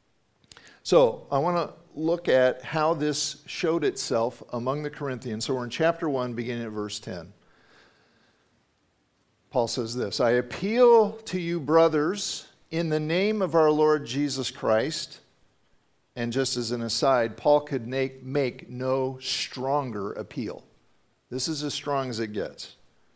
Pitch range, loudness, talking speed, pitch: 120-155 Hz, -26 LUFS, 150 wpm, 135 Hz